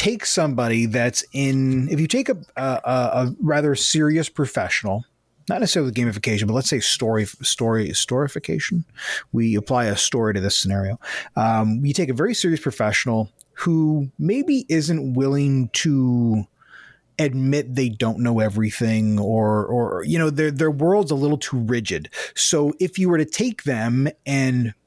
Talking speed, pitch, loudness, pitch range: 160 wpm, 130 Hz, -21 LUFS, 115-155 Hz